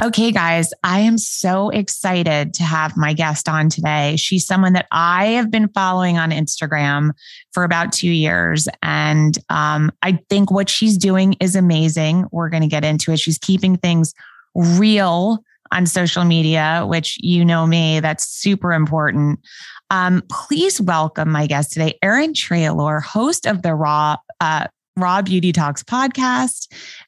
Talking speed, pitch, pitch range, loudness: 155 wpm, 170 Hz, 155-195 Hz, -17 LUFS